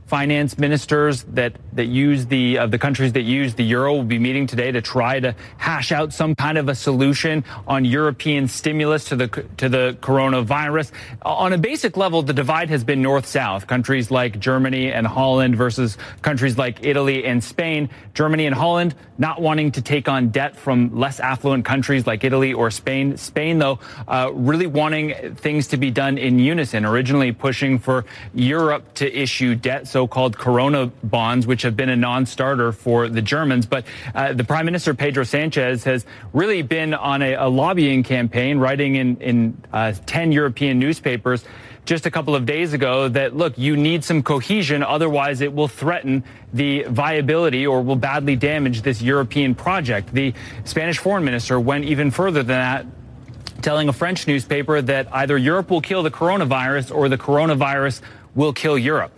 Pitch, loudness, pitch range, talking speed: 135 Hz, -19 LUFS, 125-150 Hz, 180 wpm